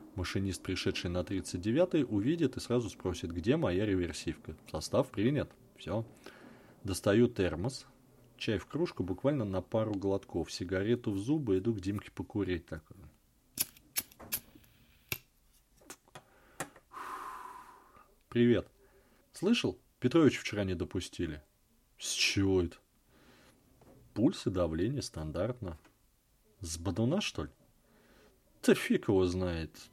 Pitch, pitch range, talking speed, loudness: 100 Hz, 90-120 Hz, 105 wpm, -33 LUFS